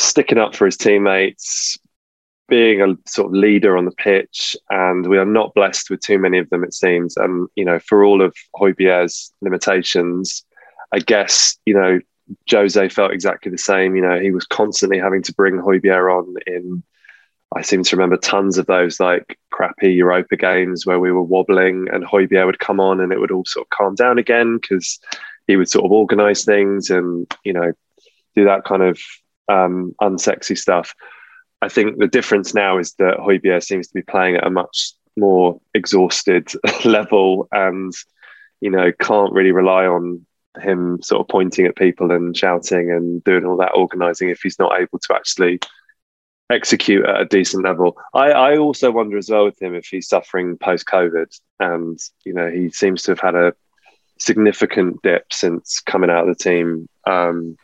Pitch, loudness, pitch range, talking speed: 95 Hz, -16 LUFS, 90-95 Hz, 185 wpm